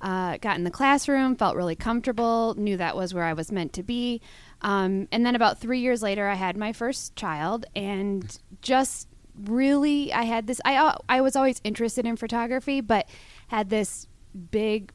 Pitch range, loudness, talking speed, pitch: 195-245 Hz, -25 LUFS, 185 wpm, 220 Hz